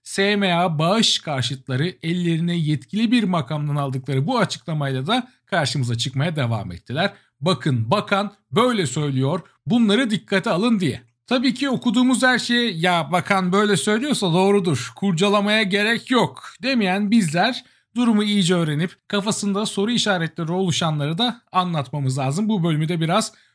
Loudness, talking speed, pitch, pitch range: -20 LUFS, 135 wpm, 185 Hz, 155-215 Hz